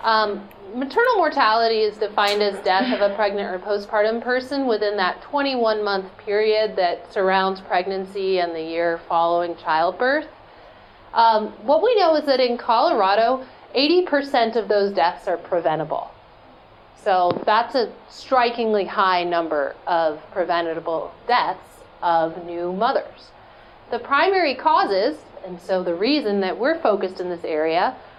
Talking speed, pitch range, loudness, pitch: 140 wpm, 175-235 Hz, -21 LUFS, 205 Hz